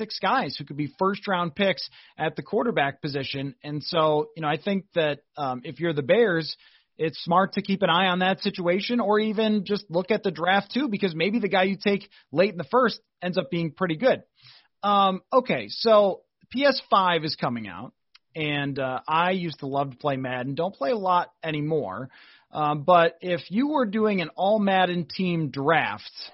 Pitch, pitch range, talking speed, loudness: 180 Hz, 150-200 Hz, 200 wpm, -25 LUFS